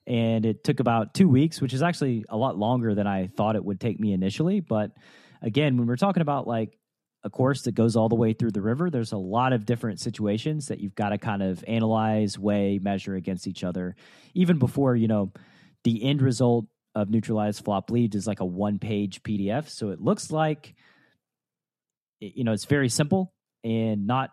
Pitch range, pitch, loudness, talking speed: 105-130 Hz, 115 Hz, -26 LUFS, 205 wpm